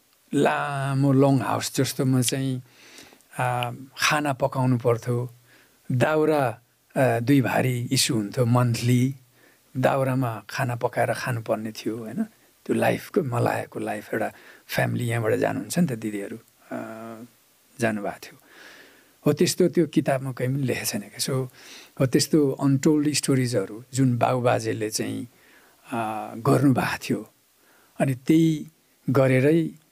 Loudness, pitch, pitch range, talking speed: -24 LUFS, 130 Hz, 120-140 Hz, 110 wpm